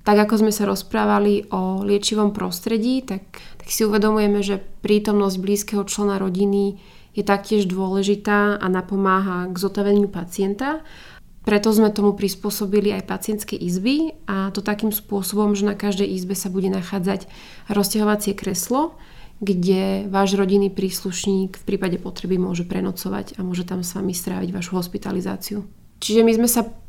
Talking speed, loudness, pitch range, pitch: 145 wpm, -21 LUFS, 190-210 Hz, 200 Hz